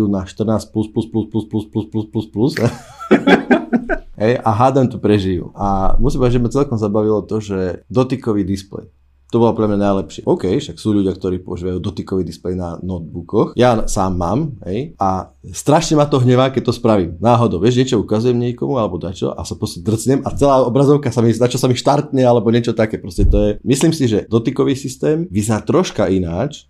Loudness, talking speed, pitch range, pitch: -16 LUFS, 200 wpm, 95-125 Hz, 110 Hz